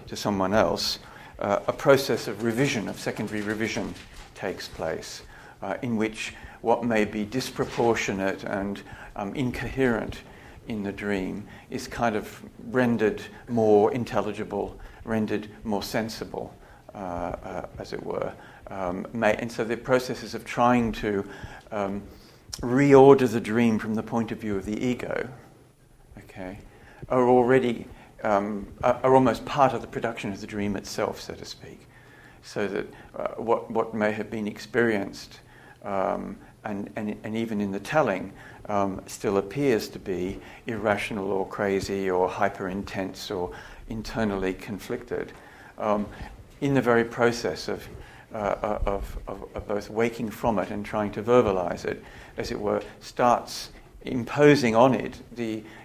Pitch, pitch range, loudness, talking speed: 110 Hz, 100-120 Hz, -26 LUFS, 145 wpm